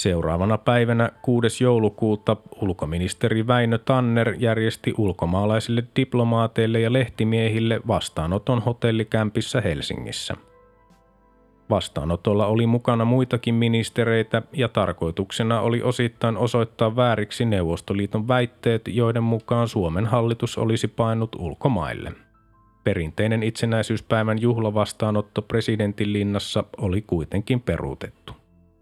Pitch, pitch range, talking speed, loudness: 110 Hz, 105-120 Hz, 90 wpm, -23 LUFS